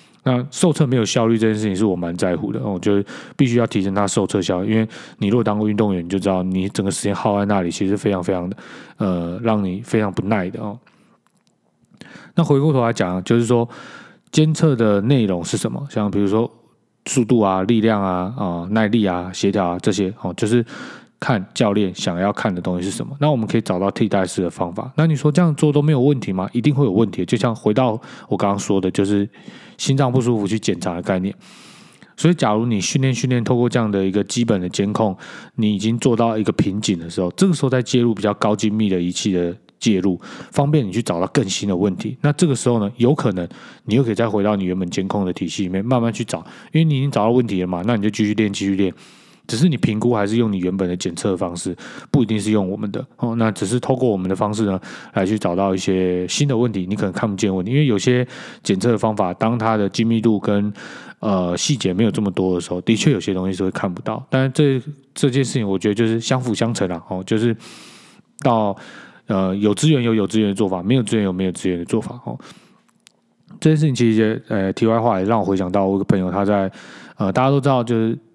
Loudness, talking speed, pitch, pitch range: -19 LUFS, 350 characters per minute, 110 Hz, 95-125 Hz